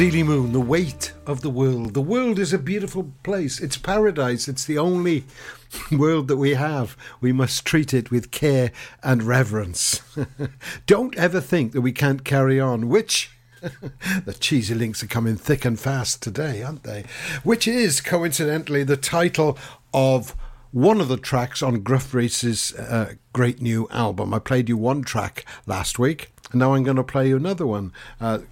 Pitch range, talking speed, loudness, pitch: 125-155 Hz, 175 wpm, -22 LUFS, 135 Hz